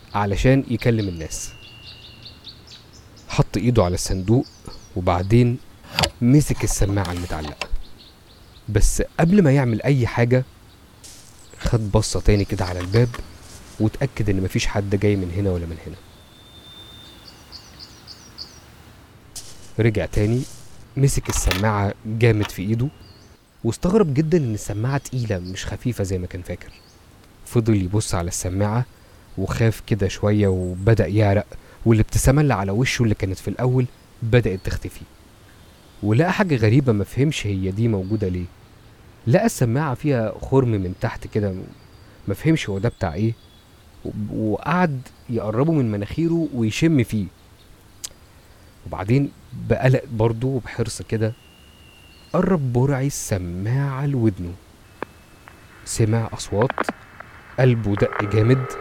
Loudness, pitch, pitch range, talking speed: -21 LUFS, 110 Hz, 95-120 Hz, 110 wpm